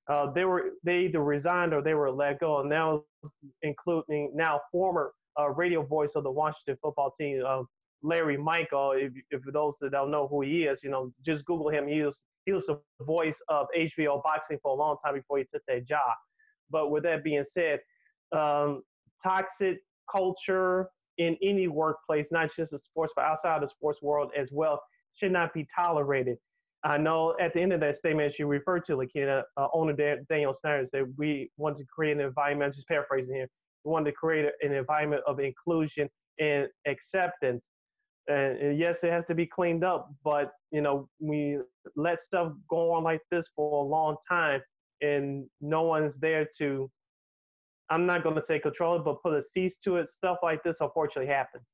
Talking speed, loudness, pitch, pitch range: 195 wpm, -30 LUFS, 150 Hz, 145-170 Hz